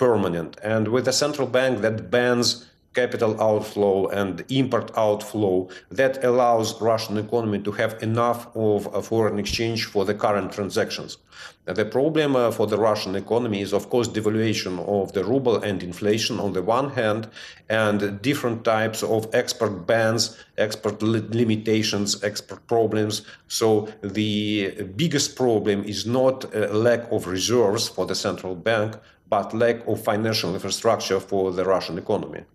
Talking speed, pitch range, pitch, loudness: 145 wpm, 100-115 Hz, 110 Hz, -23 LUFS